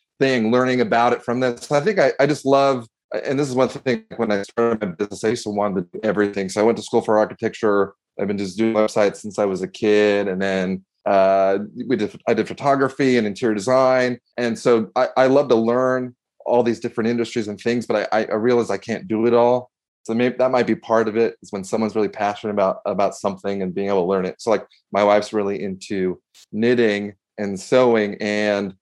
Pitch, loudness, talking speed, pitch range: 110 Hz, -20 LUFS, 230 wpm, 100-125 Hz